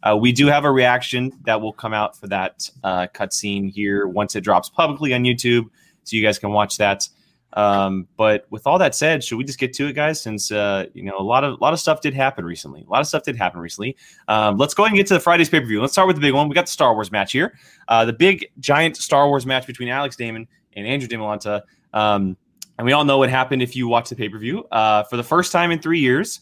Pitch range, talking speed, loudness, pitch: 105-145 Hz, 275 wpm, -19 LUFS, 125 Hz